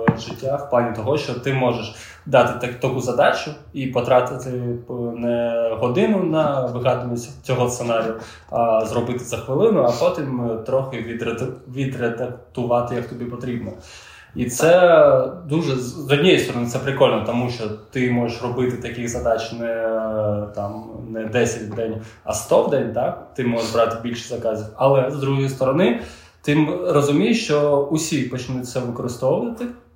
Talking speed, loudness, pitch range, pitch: 145 wpm, -21 LUFS, 115-135 Hz, 120 Hz